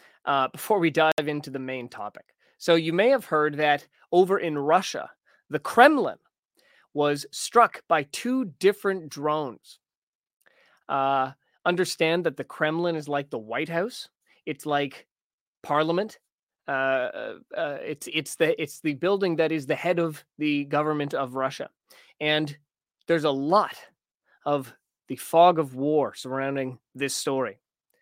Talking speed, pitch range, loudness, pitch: 145 wpm, 140-170 Hz, -25 LUFS, 155 Hz